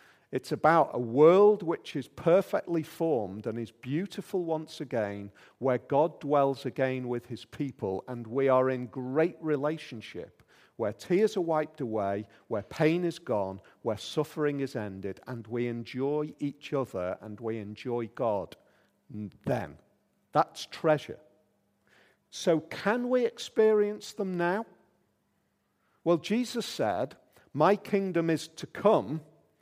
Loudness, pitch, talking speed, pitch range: -30 LUFS, 145 Hz, 130 wpm, 120-170 Hz